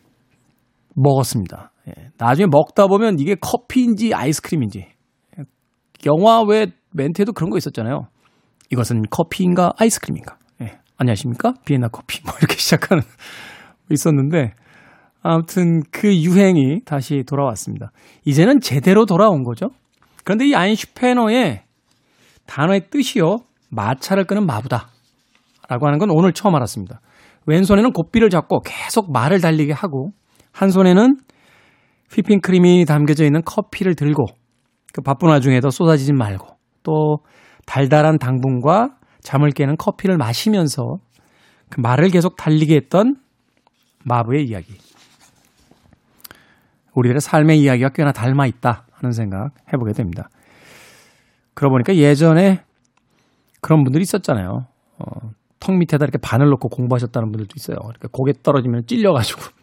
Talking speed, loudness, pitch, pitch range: 310 characters per minute, -16 LUFS, 150 Hz, 125-185 Hz